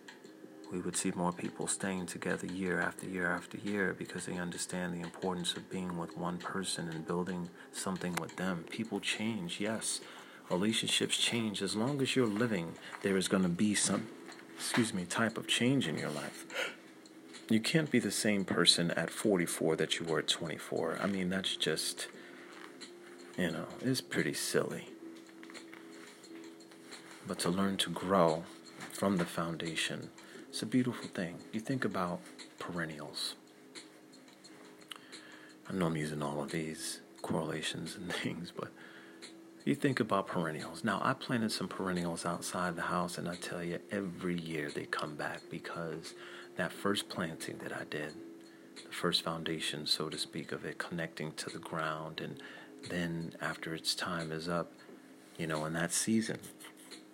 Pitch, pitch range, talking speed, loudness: 90 Hz, 80-100 Hz, 160 wpm, -35 LUFS